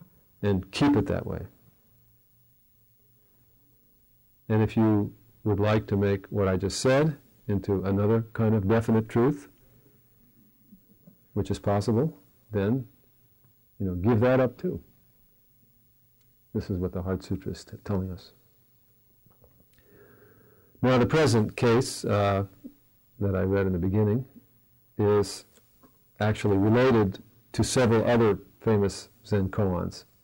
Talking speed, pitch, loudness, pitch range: 125 wpm, 110 Hz, -26 LUFS, 100-120 Hz